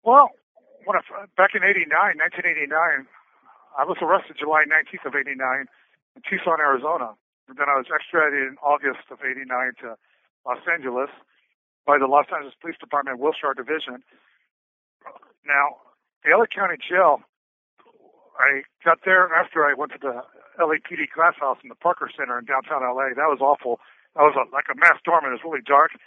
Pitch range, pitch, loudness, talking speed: 130-165 Hz, 145 Hz, -21 LUFS, 170 wpm